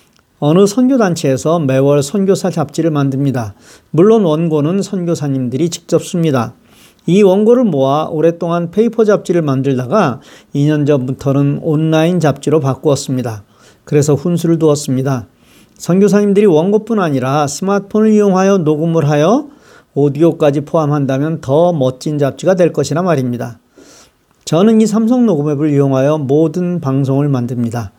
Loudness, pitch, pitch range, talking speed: -13 LUFS, 155 Hz, 140-185 Hz, 335 characters per minute